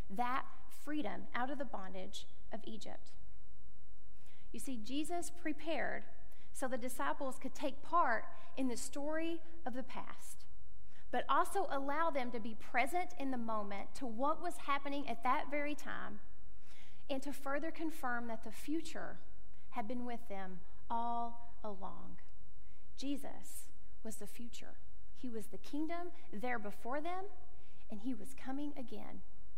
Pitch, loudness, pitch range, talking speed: 260 Hz, -42 LUFS, 225-300 Hz, 145 wpm